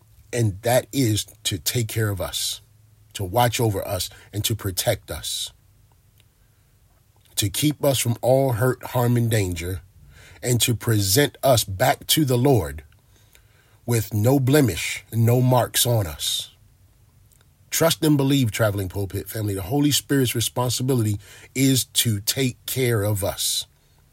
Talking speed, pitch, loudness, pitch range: 140 wpm, 110 Hz, -22 LUFS, 105-125 Hz